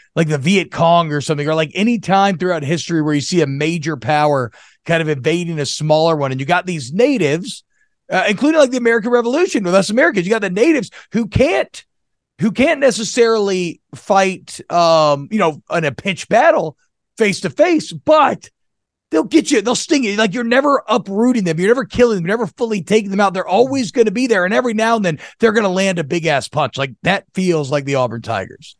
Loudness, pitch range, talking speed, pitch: -16 LUFS, 160-230 Hz, 215 wpm, 190 Hz